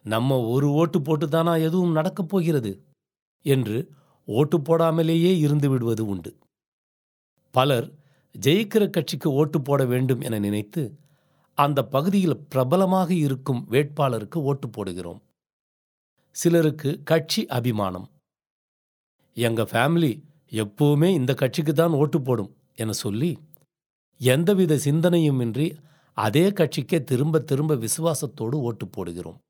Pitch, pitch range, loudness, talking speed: 145 Hz, 125-165 Hz, -23 LUFS, 100 wpm